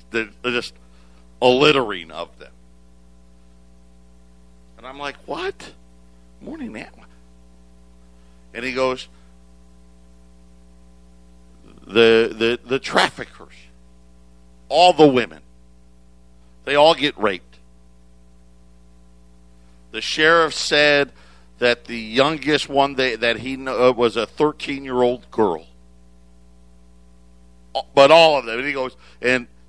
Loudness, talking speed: -18 LUFS, 100 wpm